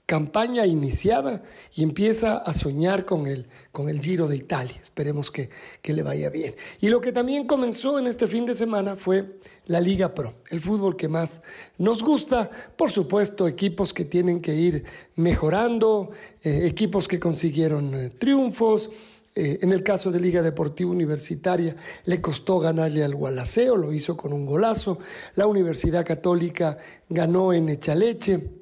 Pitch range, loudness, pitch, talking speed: 160-210 Hz, -24 LUFS, 180 Hz, 160 wpm